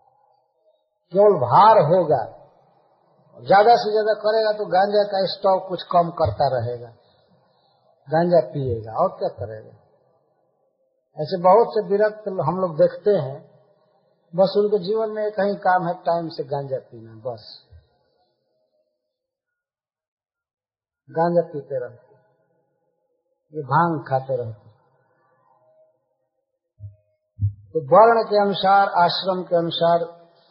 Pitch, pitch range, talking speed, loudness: 180 Hz, 155-210 Hz, 105 wpm, -20 LUFS